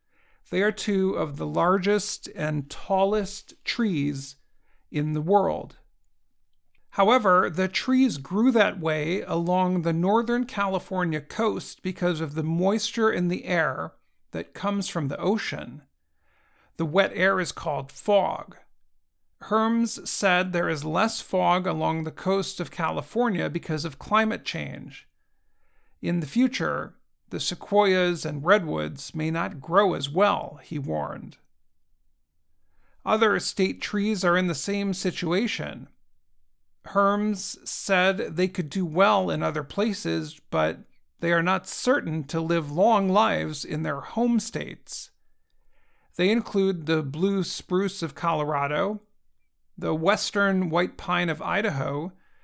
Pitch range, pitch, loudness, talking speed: 155-200 Hz, 180 Hz, -25 LUFS, 130 wpm